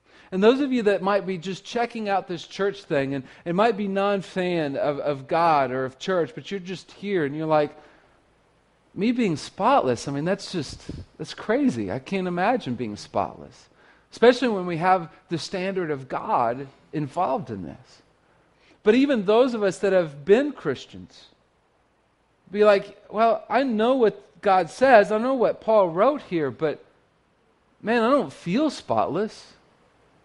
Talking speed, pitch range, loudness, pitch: 170 wpm, 155-220 Hz, -23 LUFS, 190 Hz